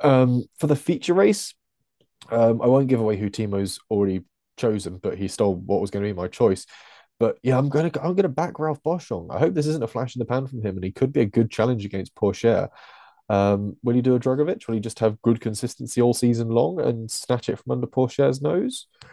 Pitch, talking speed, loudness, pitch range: 120 Hz, 240 wpm, -23 LUFS, 105-135 Hz